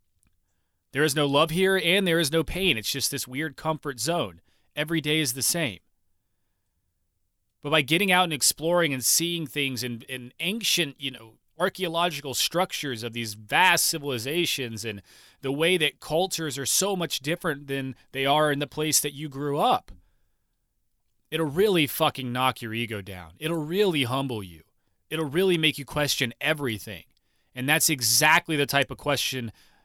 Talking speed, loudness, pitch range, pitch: 170 wpm, -25 LUFS, 115-160 Hz, 140 Hz